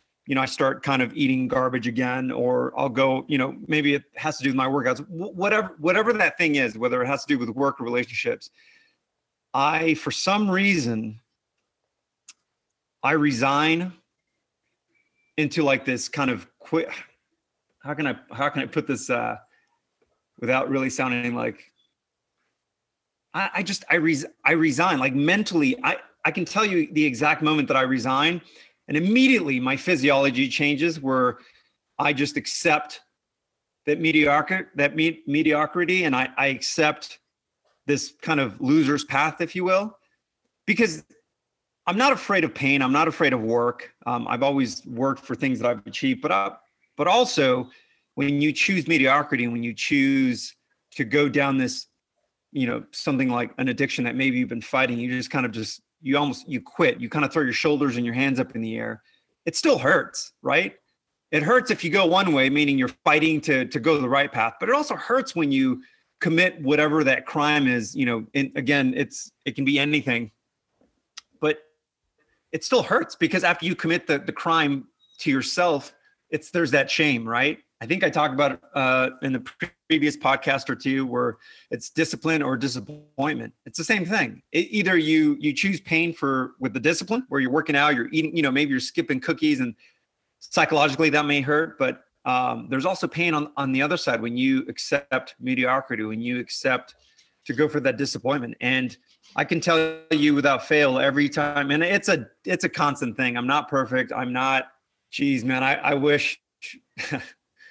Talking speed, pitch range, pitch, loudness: 185 wpm, 130-165 Hz, 145 Hz, -23 LUFS